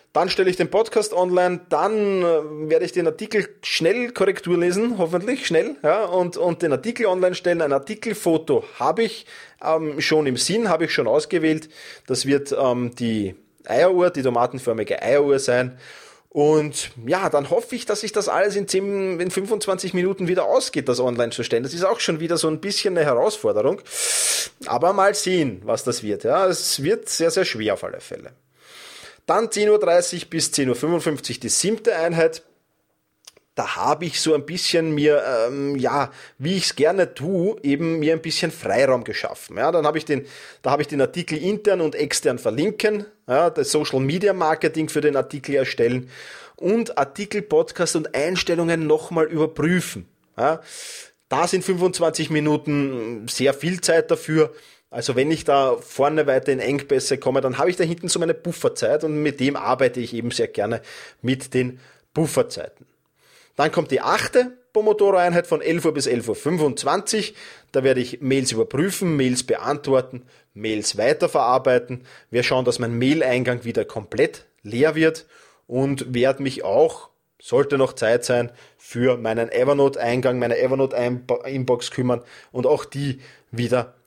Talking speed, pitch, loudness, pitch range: 165 wpm, 160 Hz, -21 LUFS, 135-190 Hz